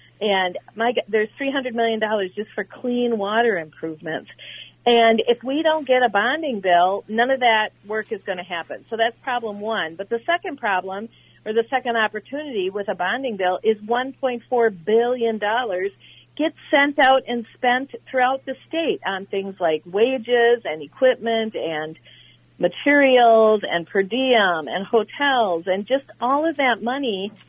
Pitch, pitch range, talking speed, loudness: 230 Hz, 200-255 Hz, 160 wpm, -21 LUFS